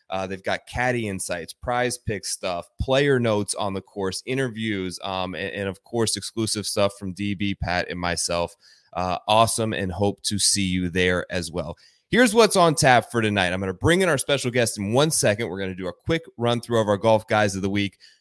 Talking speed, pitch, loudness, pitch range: 225 wpm, 100 Hz, -23 LUFS, 95-120 Hz